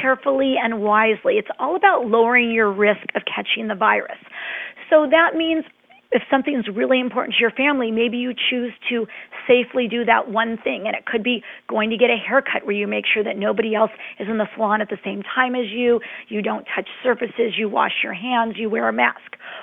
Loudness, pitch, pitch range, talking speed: -20 LUFS, 230 Hz, 215-250 Hz, 215 wpm